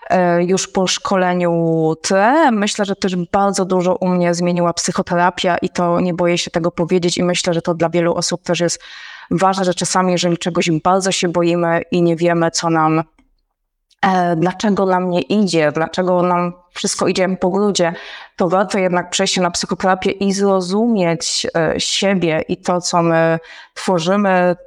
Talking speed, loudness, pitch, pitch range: 165 wpm, -16 LUFS, 180 Hz, 175-190 Hz